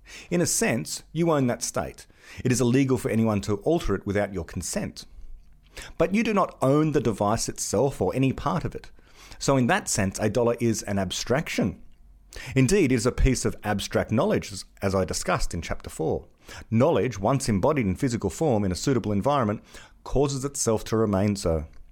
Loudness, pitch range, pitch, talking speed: -25 LUFS, 100-130 Hz, 110 Hz, 190 wpm